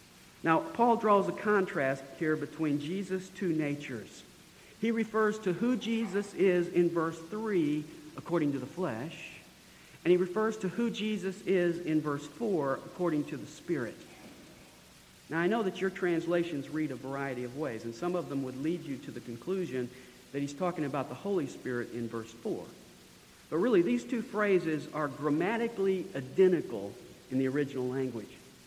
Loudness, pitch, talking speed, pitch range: -32 LUFS, 165 Hz, 165 wpm, 135-190 Hz